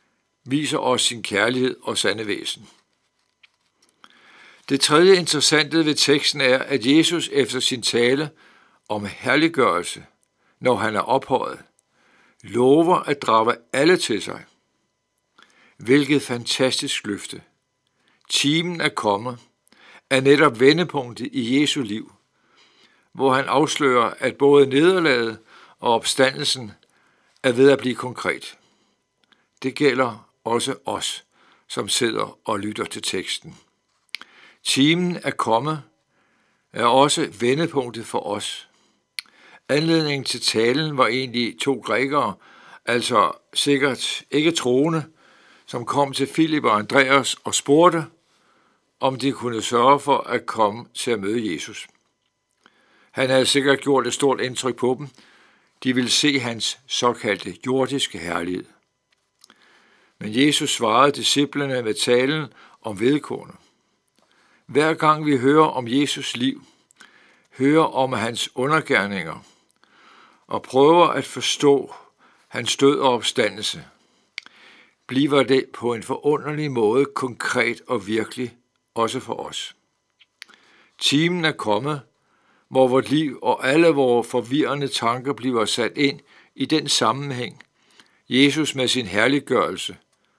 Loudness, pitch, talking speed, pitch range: -20 LUFS, 135 Hz, 120 wpm, 125-145 Hz